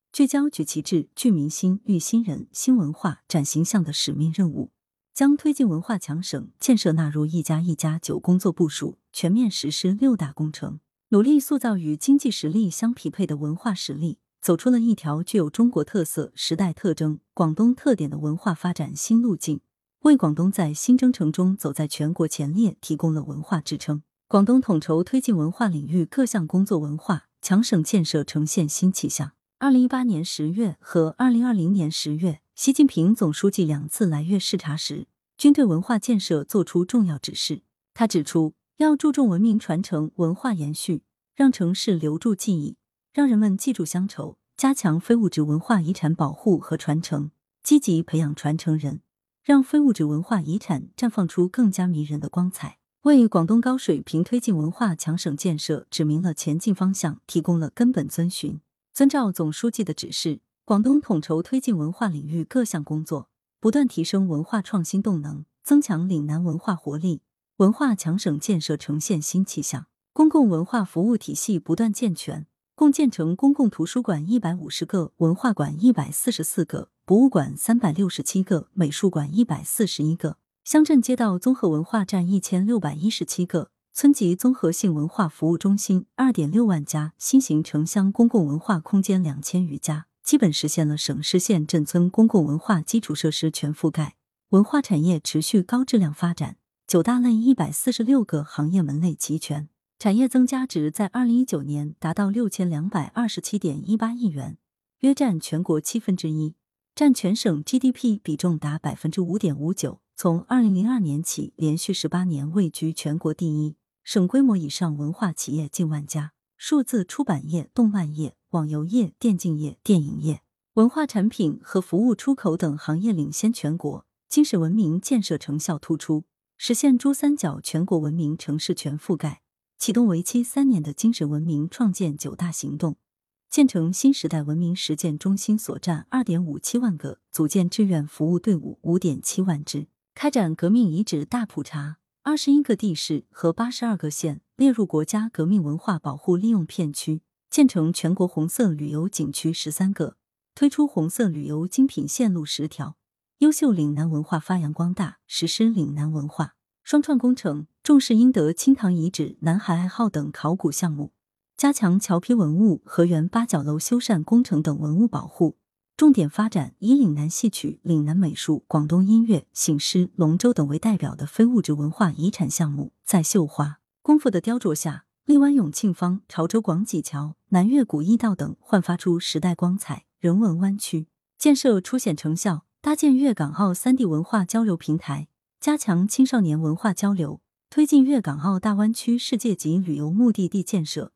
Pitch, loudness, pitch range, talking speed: 180 Hz, -22 LUFS, 155-225 Hz, 280 characters per minute